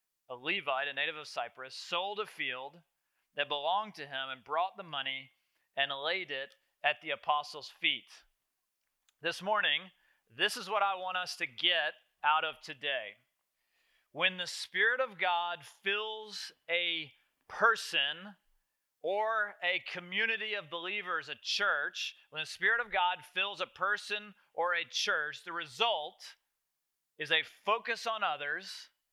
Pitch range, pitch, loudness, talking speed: 150-205 Hz, 180 Hz, -33 LUFS, 145 wpm